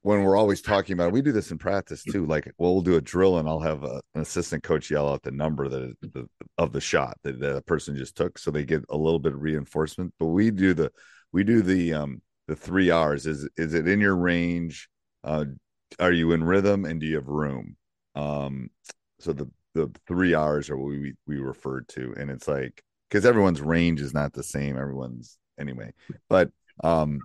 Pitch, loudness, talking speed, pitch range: 80 Hz, -26 LUFS, 220 wpm, 70-90 Hz